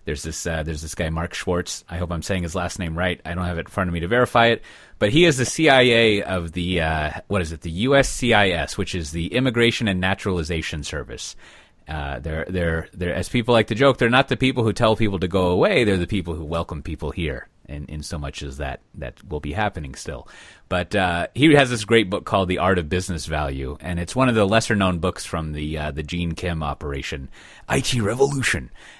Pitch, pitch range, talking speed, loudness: 90 Hz, 80-105 Hz, 240 wpm, -21 LUFS